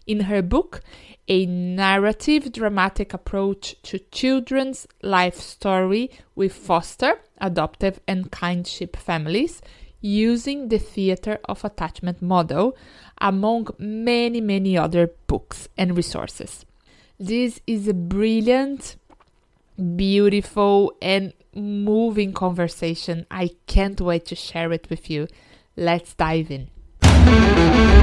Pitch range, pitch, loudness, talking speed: 175-215 Hz, 195 Hz, -21 LUFS, 105 wpm